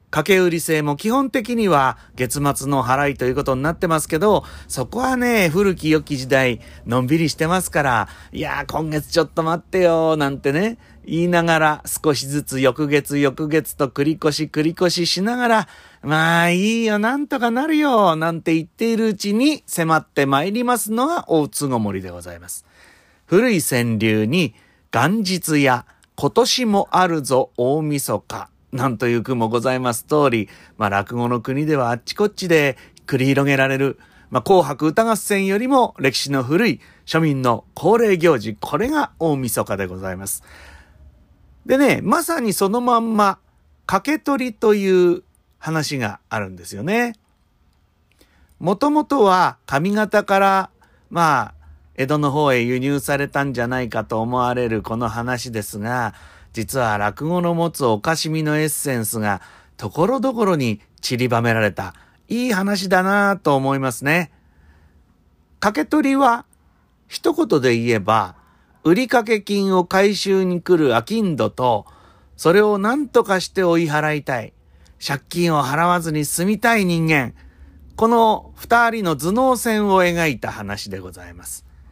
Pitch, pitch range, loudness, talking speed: 150 Hz, 120-195 Hz, -19 LUFS, 290 characters per minute